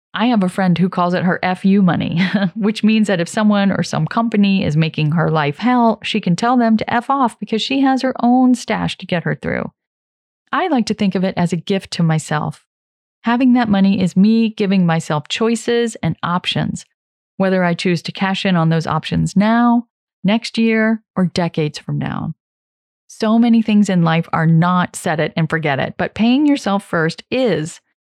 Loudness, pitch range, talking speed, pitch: -16 LUFS, 170-225 Hz, 200 wpm, 195 Hz